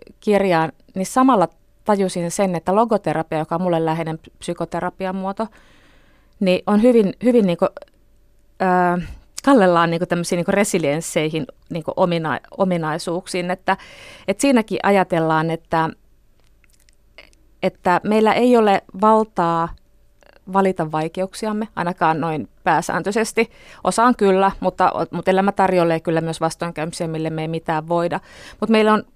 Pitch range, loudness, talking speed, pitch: 165-200 Hz, -19 LUFS, 115 wpm, 180 Hz